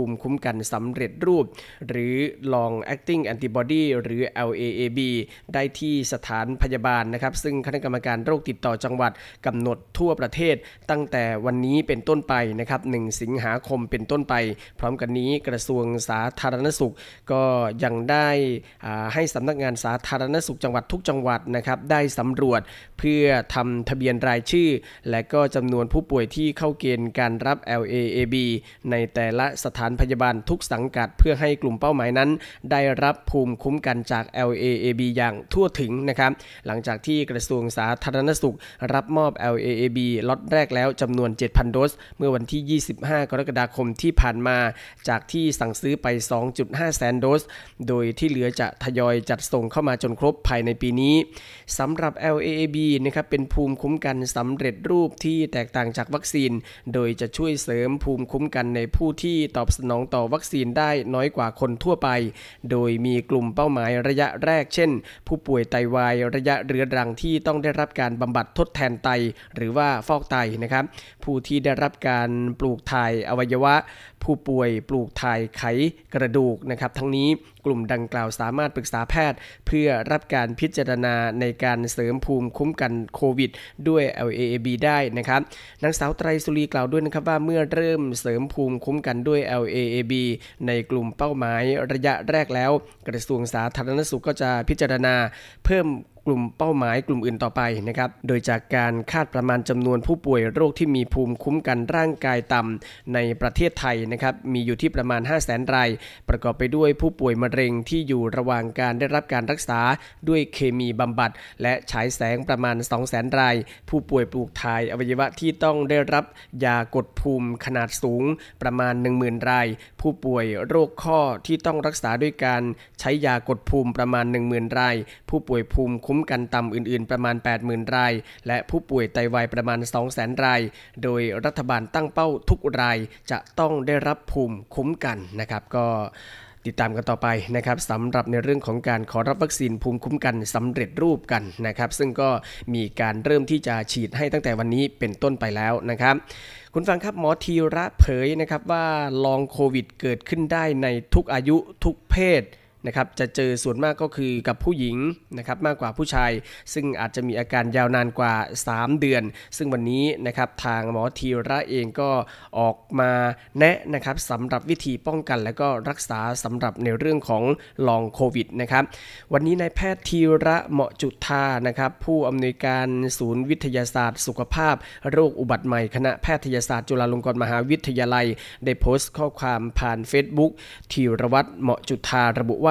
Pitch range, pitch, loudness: 120-145 Hz, 125 Hz, -23 LUFS